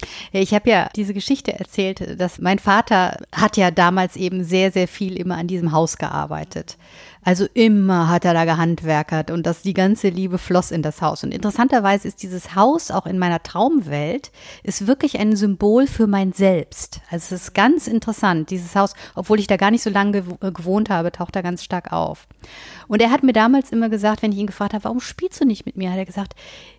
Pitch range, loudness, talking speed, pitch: 180-215 Hz, -19 LUFS, 210 wpm, 195 Hz